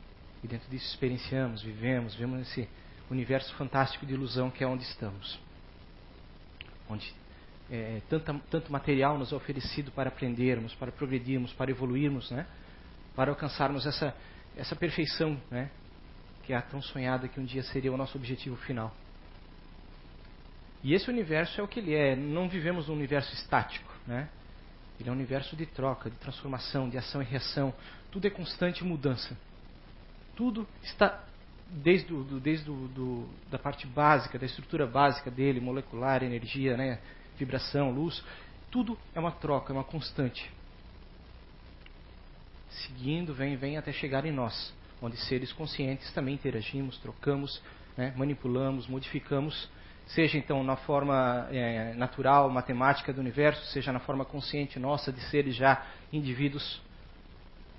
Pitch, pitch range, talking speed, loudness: 135 Hz, 120-145 Hz, 140 wpm, -32 LUFS